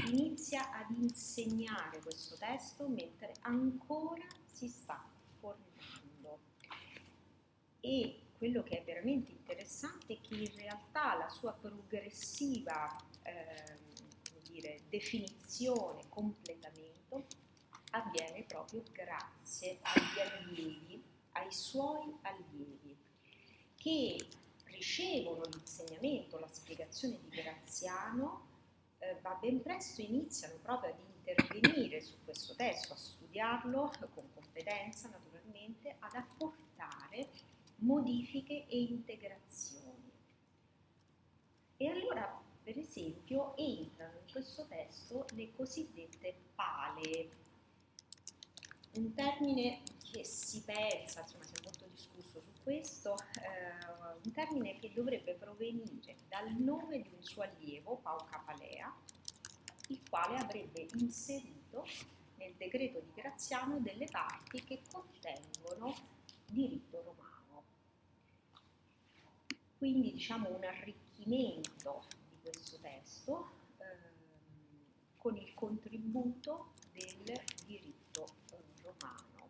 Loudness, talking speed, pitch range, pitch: -41 LUFS, 95 wpm, 170-265 Hz, 225 Hz